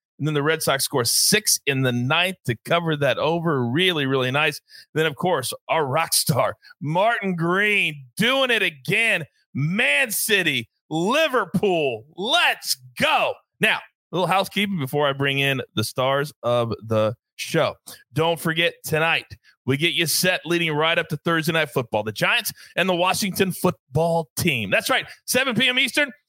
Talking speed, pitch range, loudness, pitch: 165 wpm, 140-190 Hz, -21 LUFS, 165 Hz